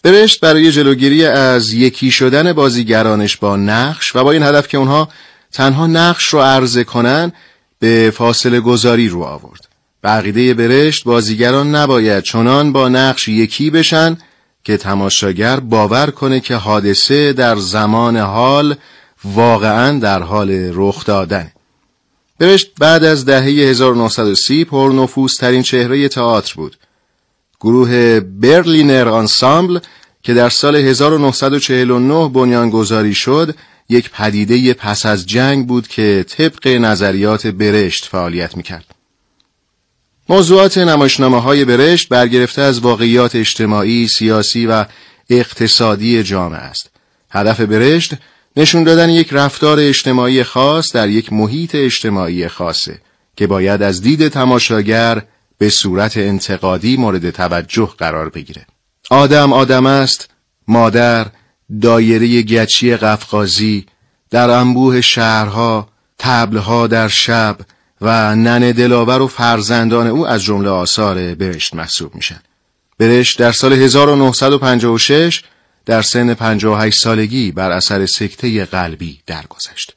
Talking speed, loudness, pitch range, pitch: 115 wpm, -11 LUFS, 105-135 Hz, 120 Hz